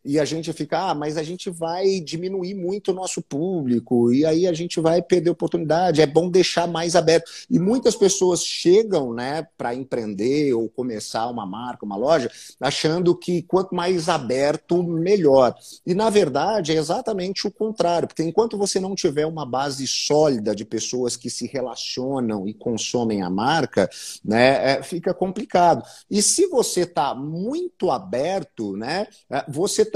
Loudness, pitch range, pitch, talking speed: -21 LUFS, 135-185 Hz, 165 Hz, 160 wpm